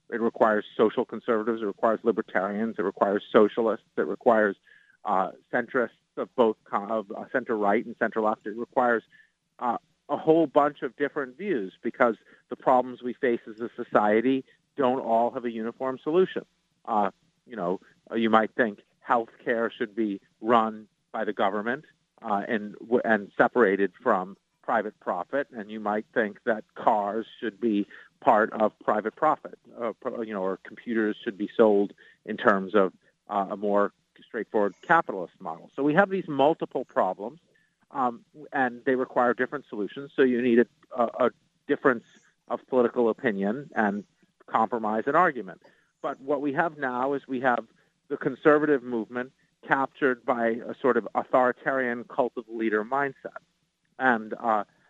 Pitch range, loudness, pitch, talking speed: 110-135 Hz, -27 LUFS, 120 Hz, 155 wpm